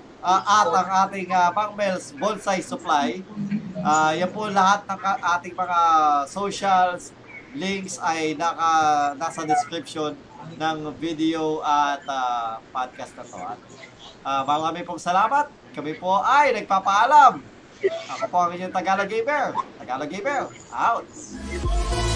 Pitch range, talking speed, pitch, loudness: 155-195 Hz, 120 wpm, 180 Hz, -22 LUFS